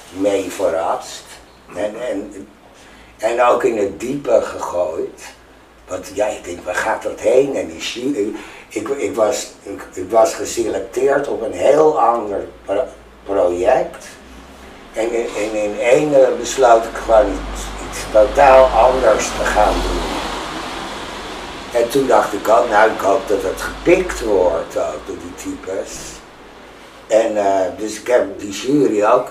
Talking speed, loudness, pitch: 145 wpm, -17 LUFS, 135 Hz